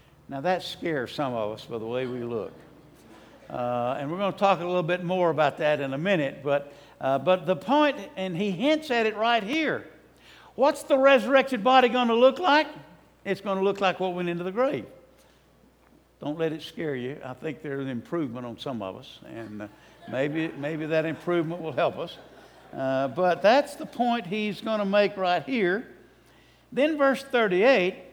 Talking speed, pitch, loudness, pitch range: 200 wpm, 180 Hz, -26 LUFS, 140-230 Hz